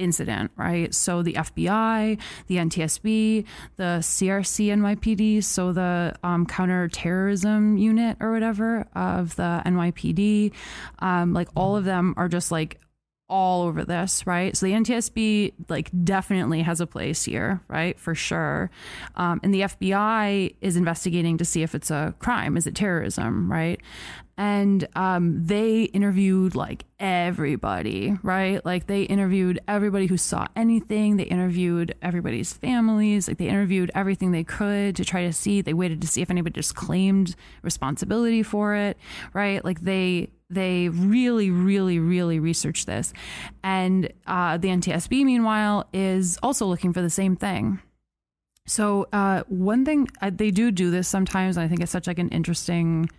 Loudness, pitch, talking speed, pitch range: -24 LUFS, 185 Hz, 155 wpm, 175-205 Hz